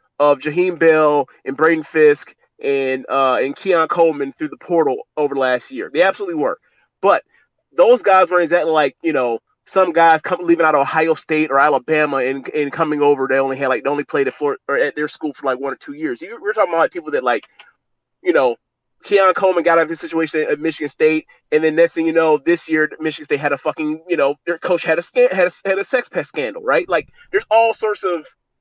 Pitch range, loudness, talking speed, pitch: 145-185 Hz, -17 LUFS, 235 wpm, 160 Hz